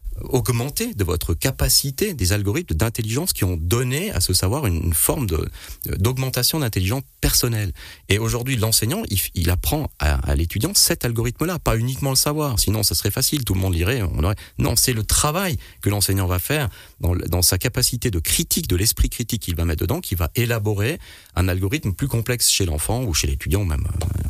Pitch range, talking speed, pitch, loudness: 90-125 Hz, 195 wpm, 100 Hz, -20 LUFS